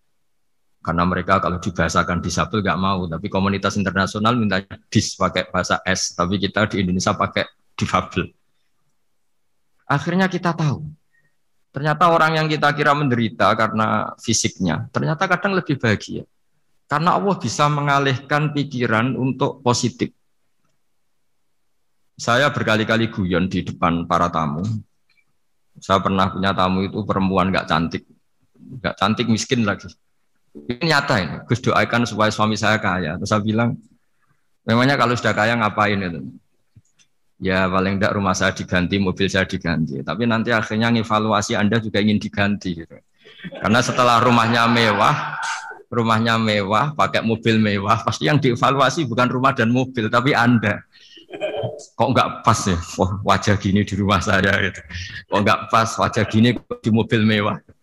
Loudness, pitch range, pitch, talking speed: -19 LUFS, 95-120 Hz, 110 Hz, 140 wpm